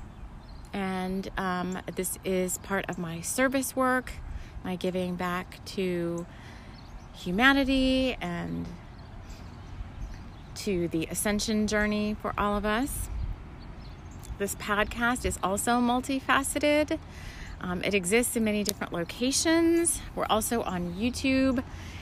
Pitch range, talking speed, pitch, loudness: 175-245 Hz, 105 wpm, 200 Hz, -28 LUFS